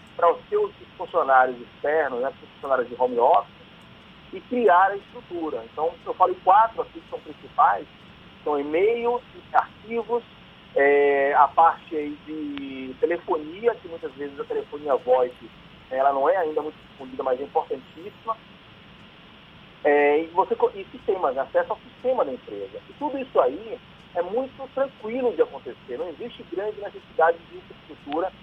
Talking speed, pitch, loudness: 150 wpm, 190 Hz, -24 LUFS